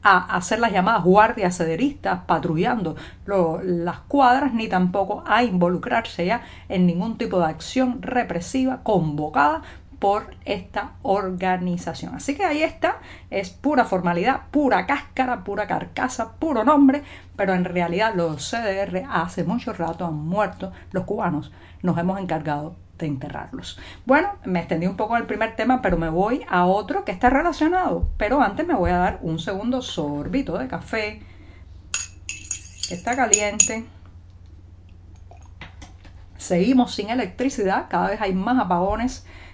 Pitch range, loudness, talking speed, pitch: 165-235 Hz, -22 LUFS, 140 wpm, 195 Hz